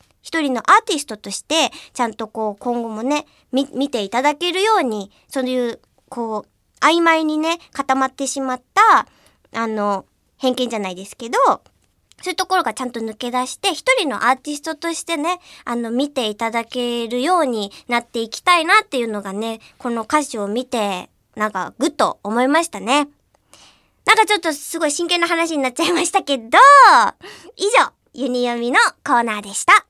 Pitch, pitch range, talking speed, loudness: 255 Hz, 230-325 Hz, 355 characters per minute, -18 LUFS